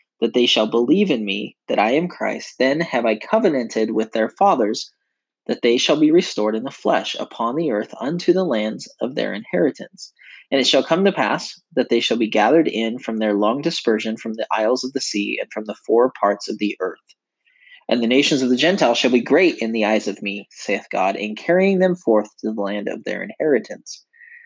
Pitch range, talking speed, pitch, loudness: 110-140 Hz, 220 wpm, 115 Hz, -19 LUFS